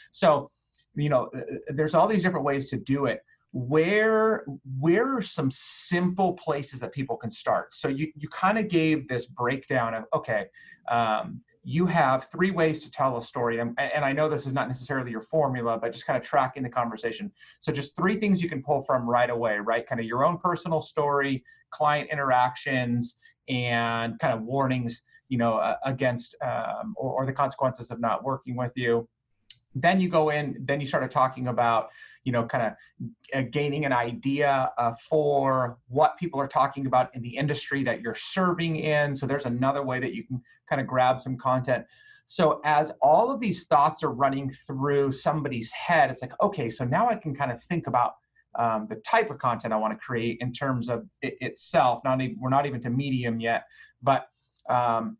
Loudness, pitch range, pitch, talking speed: -26 LUFS, 120-155 Hz, 135 Hz, 200 wpm